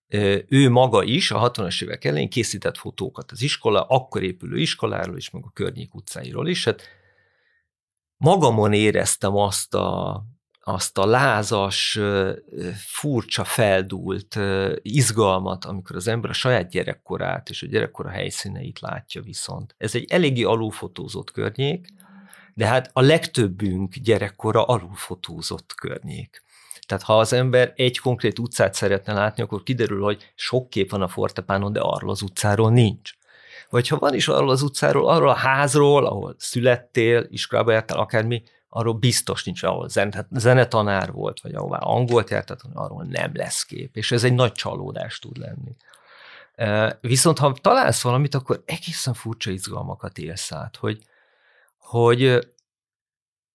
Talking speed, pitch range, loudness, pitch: 140 wpm, 100-125 Hz, -21 LUFS, 115 Hz